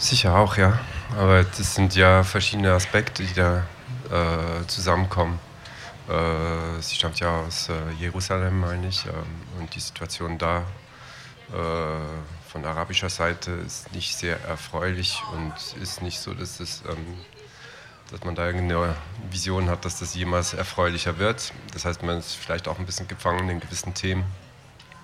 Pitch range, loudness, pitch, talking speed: 85-100 Hz, -25 LUFS, 90 Hz, 155 wpm